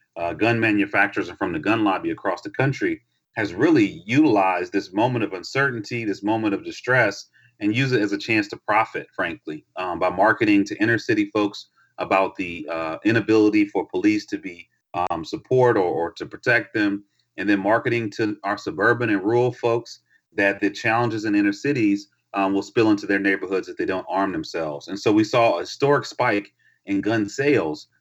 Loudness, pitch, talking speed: -22 LUFS, 115 Hz, 190 wpm